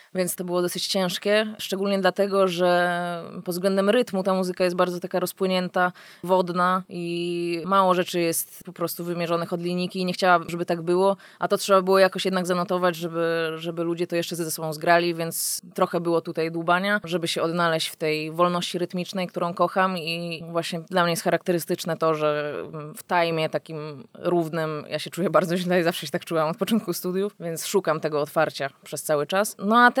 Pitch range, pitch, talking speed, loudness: 165-185 Hz, 175 Hz, 190 wpm, -24 LUFS